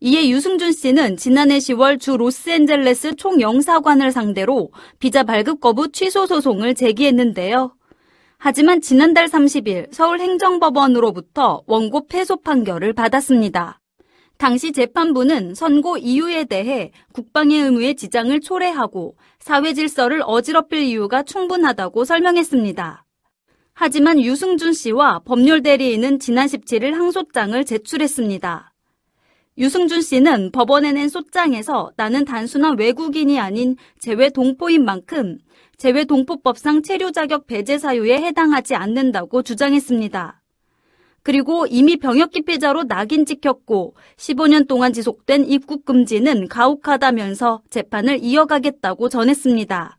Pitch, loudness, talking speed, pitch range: 270 Hz, -16 LUFS, 305 characters per minute, 245-305 Hz